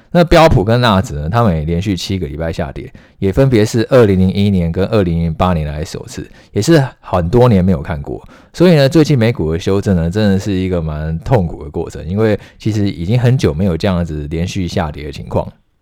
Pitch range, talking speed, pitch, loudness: 85-115 Hz, 330 characters per minute, 95 Hz, -14 LUFS